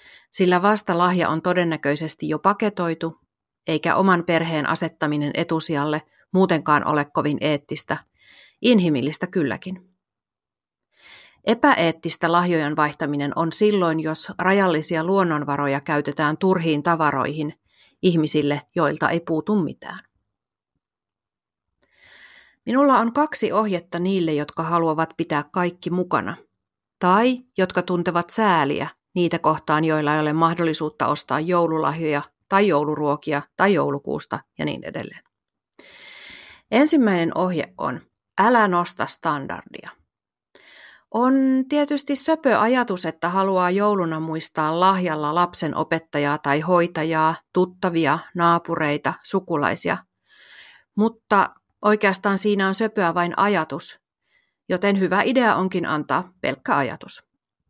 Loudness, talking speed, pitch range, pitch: -21 LUFS, 105 wpm, 155-195 Hz, 170 Hz